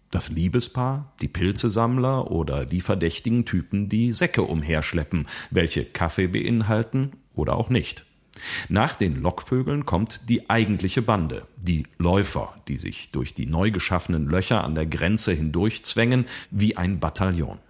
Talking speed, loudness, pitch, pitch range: 135 wpm, -24 LUFS, 100 Hz, 85-115 Hz